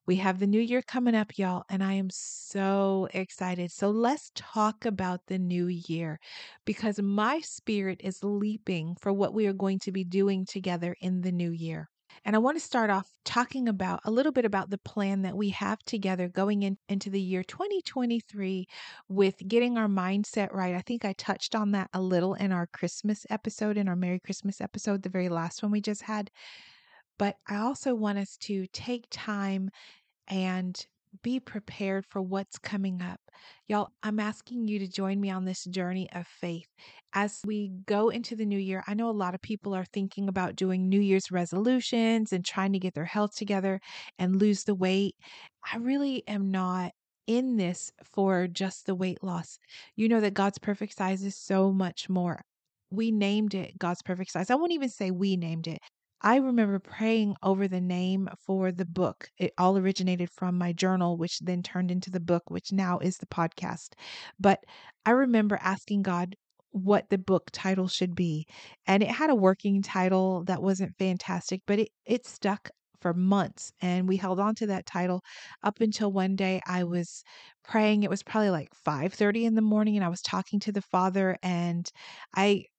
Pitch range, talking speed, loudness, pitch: 185-210 Hz, 195 wpm, -29 LUFS, 195 Hz